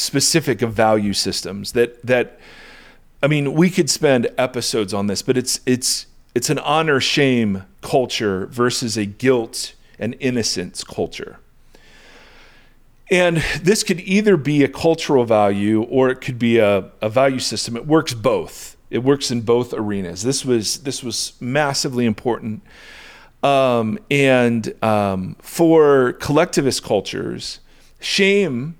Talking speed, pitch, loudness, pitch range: 135 wpm, 125 Hz, -18 LUFS, 110-140 Hz